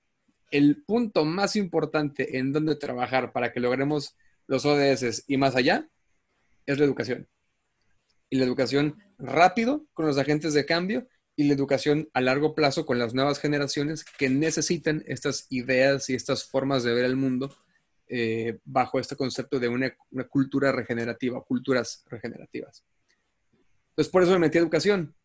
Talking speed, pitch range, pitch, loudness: 160 wpm, 130-155 Hz, 140 Hz, -25 LUFS